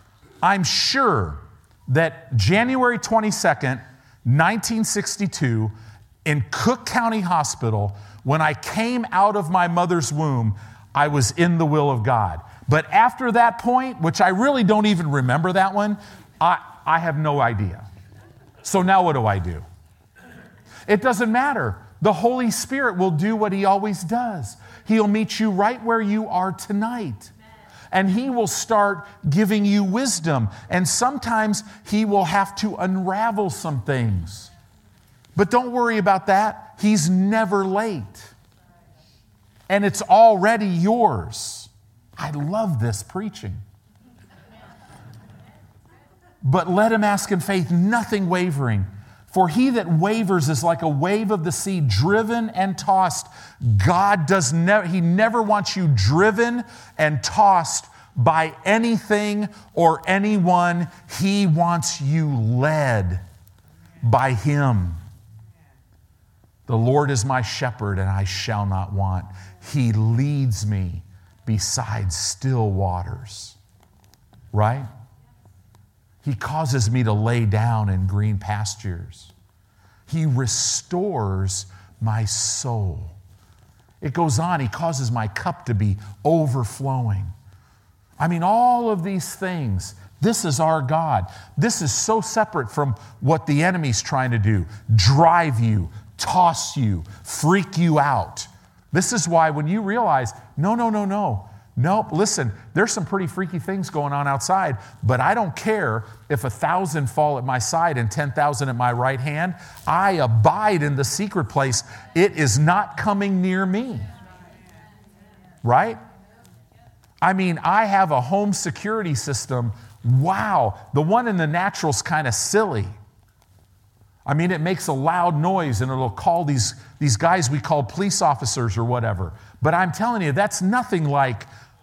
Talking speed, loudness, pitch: 140 wpm, -21 LUFS, 145 Hz